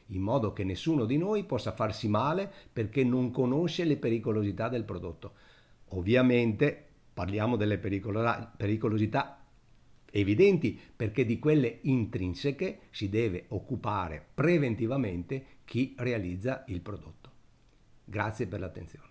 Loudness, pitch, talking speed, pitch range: -30 LUFS, 115 Hz, 115 wpm, 105-130 Hz